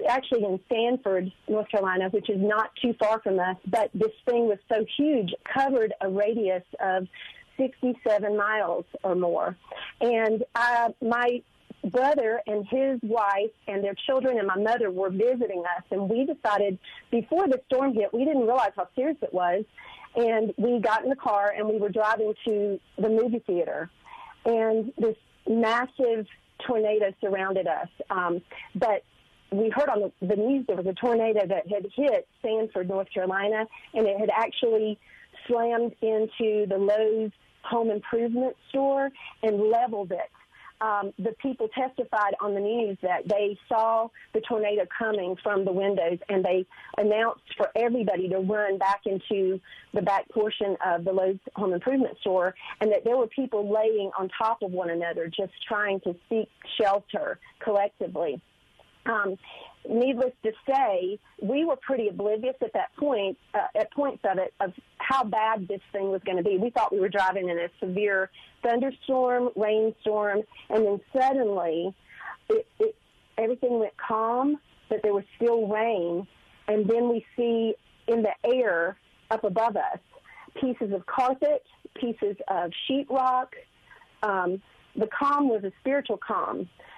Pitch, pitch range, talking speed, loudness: 220 Hz, 200-240 Hz, 160 wpm, -27 LUFS